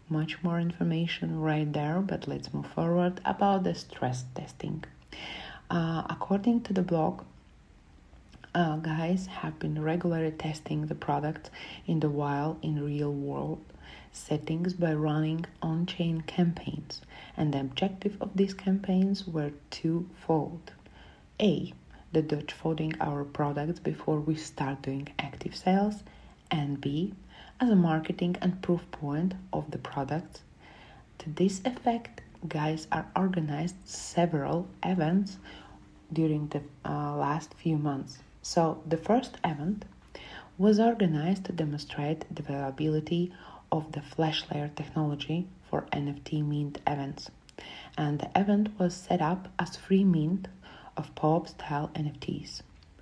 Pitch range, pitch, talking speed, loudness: 145-180 Hz, 160 Hz, 125 wpm, -31 LUFS